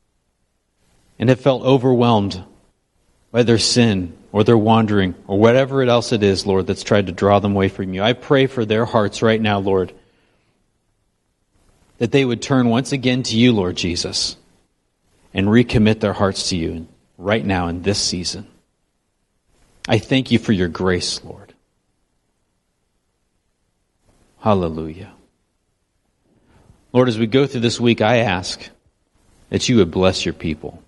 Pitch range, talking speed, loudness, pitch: 95-120 Hz, 150 wpm, -17 LUFS, 100 Hz